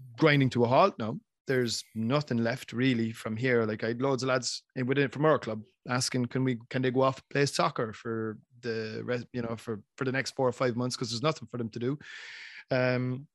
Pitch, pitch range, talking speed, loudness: 125 Hz, 115-130 Hz, 235 wpm, -30 LUFS